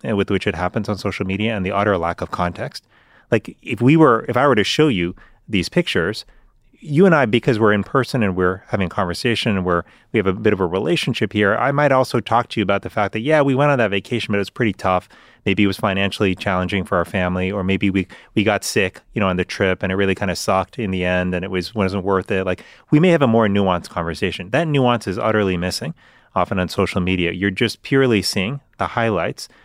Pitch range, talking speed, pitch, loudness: 95-120 Hz, 255 wpm, 100 Hz, -19 LUFS